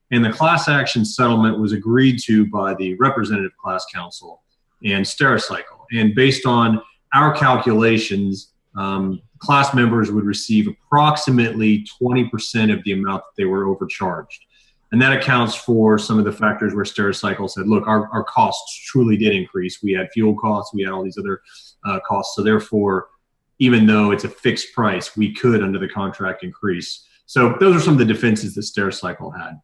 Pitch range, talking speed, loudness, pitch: 100-120 Hz, 175 wpm, -18 LUFS, 110 Hz